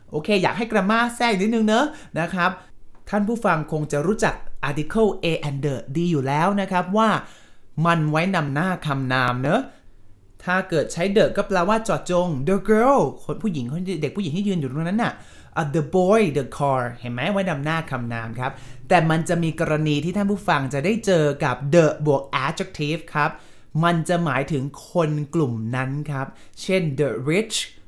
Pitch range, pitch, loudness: 145-190 Hz, 165 Hz, -22 LUFS